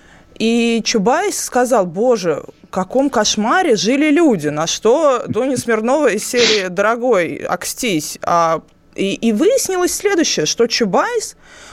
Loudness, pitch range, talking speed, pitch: -15 LUFS, 210-300 Hz, 125 wpm, 235 Hz